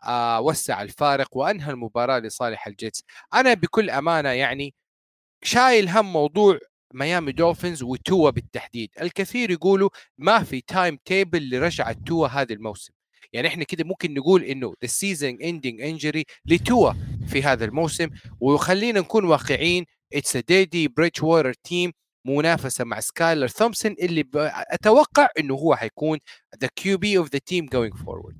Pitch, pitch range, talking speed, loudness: 155 Hz, 130-180 Hz, 140 wpm, -22 LUFS